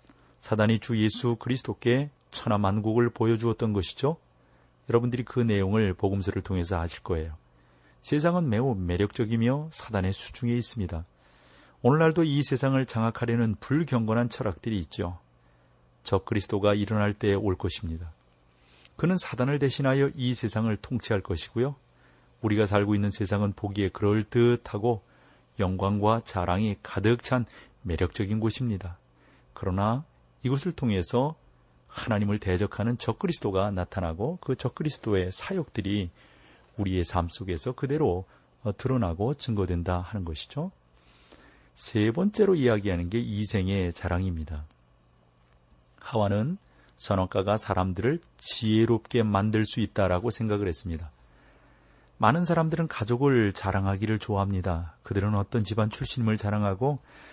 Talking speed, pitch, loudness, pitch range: 315 characters per minute, 105 Hz, -28 LUFS, 90-120 Hz